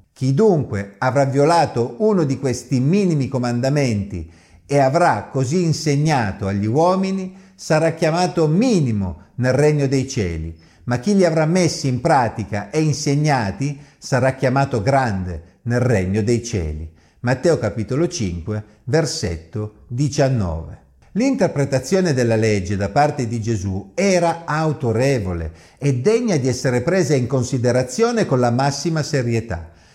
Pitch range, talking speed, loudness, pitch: 105-155 Hz, 125 wpm, -19 LUFS, 130 Hz